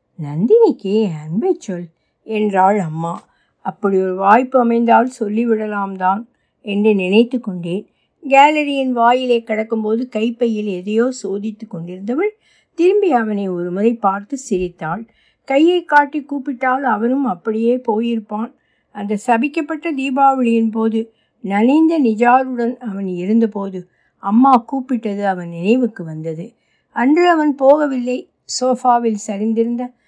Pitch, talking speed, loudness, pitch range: 230 Hz, 100 wpm, -16 LUFS, 200-255 Hz